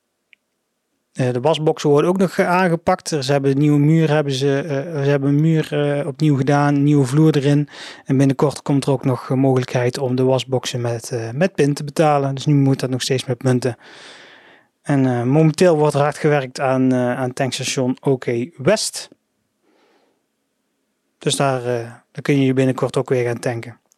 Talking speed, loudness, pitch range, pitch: 185 wpm, -18 LUFS, 130-150 Hz, 140 Hz